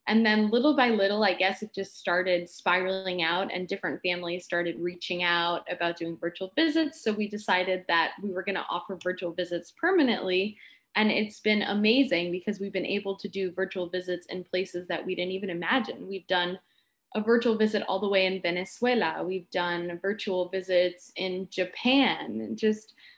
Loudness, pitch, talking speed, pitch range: -28 LUFS, 185 Hz, 185 wpm, 180-210 Hz